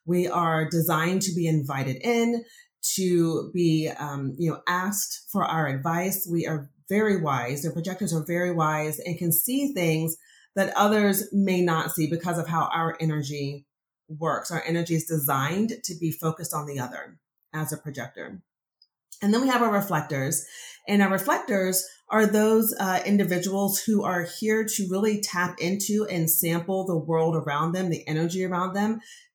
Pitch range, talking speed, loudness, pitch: 160-200 Hz, 170 wpm, -25 LUFS, 175 Hz